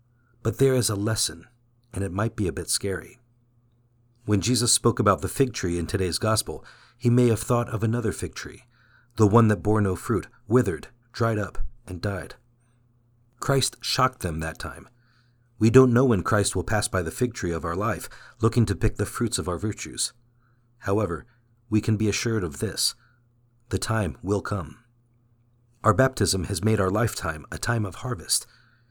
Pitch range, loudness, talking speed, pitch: 100-120 Hz, -25 LUFS, 185 wpm, 115 Hz